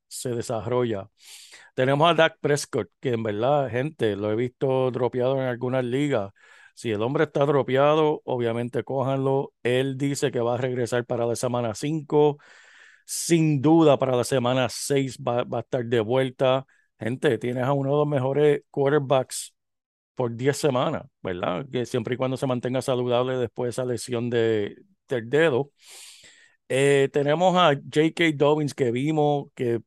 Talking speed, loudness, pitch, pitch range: 160 wpm, -24 LUFS, 130 Hz, 125-145 Hz